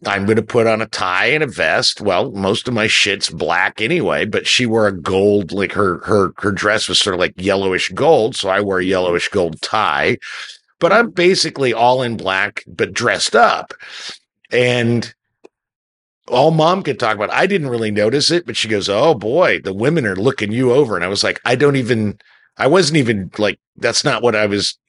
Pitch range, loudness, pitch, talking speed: 100-130 Hz, -15 LUFS, 110 Hz, 210 wpm